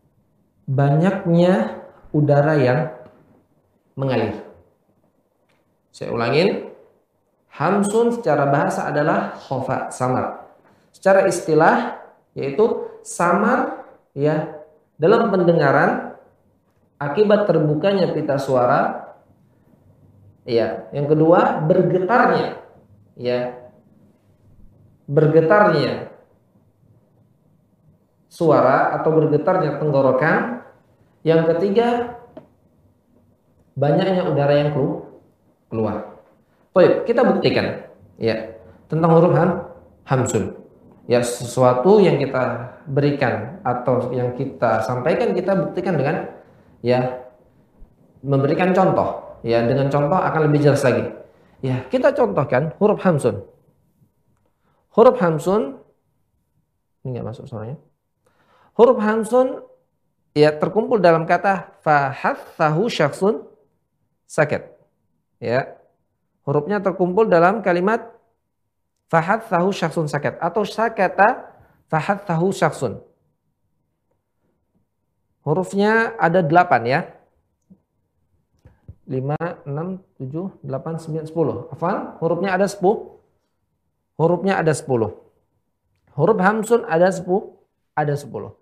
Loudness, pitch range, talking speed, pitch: -19 LUFS, 125-190 Hz, 85 wpm, 155 Hz